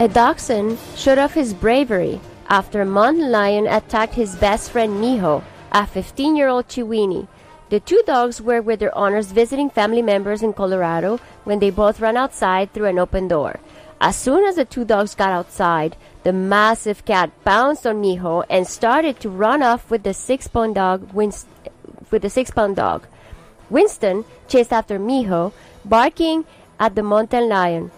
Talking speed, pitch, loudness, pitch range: 165 wpm, 215 Hz, -18 LUFS, 200-245 Hz